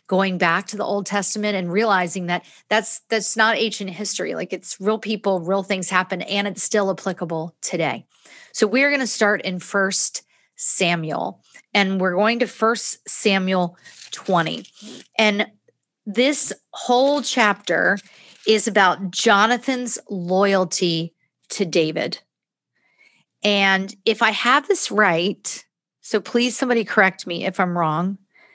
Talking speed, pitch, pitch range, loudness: 135 wpm, 200 Hz, 185-220 Hz, -20 LUFS